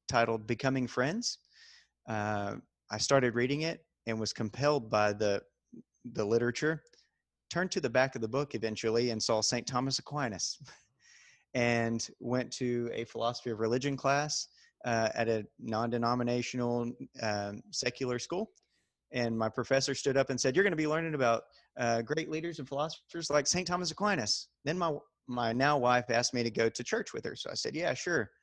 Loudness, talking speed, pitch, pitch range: -32 LUFS, 175 wpm, 125 Hz, 115-145 Hz